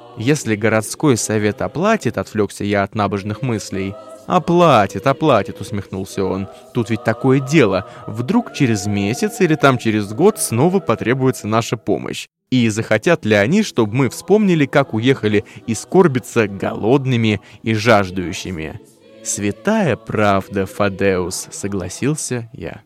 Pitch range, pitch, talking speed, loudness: 100-135 Hz, 115 Hz, 125 wpm, -17 LUFS